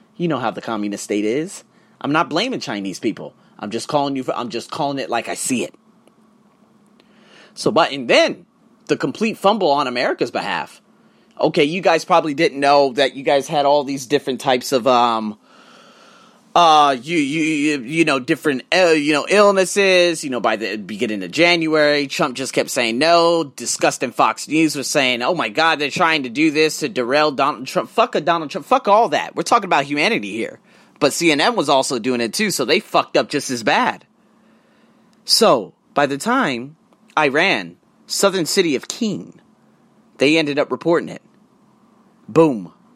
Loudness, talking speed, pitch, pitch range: -17 LUFS, 185 wpm, 155 Hz, 135-200 Hz